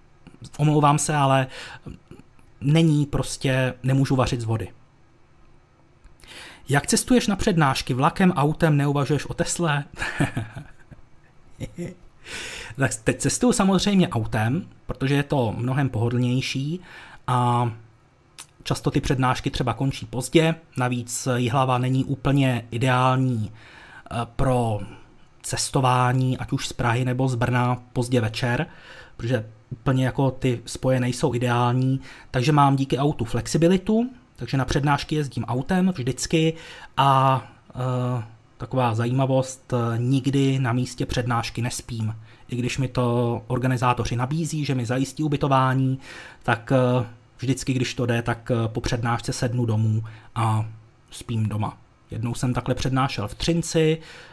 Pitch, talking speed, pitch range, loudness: 130 Hz, 120 wpm, 120-140 Hz, -23 LUFS